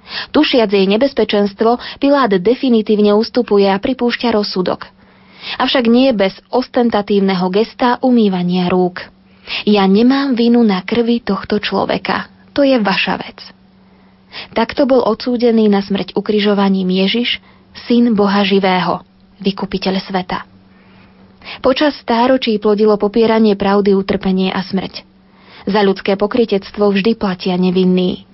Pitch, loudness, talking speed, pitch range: 205 Hz, -14 LUFS, 115 wpm, 195-235 Hz